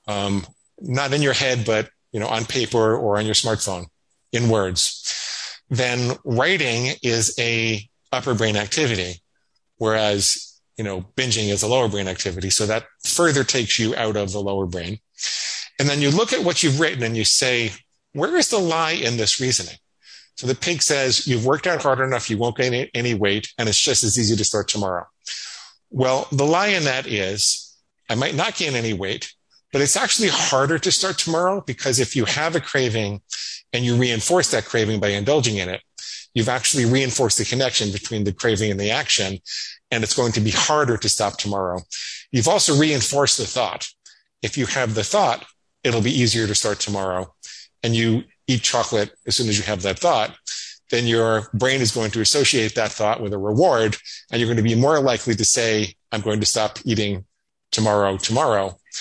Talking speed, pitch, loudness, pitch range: 195 wpm, 115 Hz, -20 LUFS, 105-130 Hz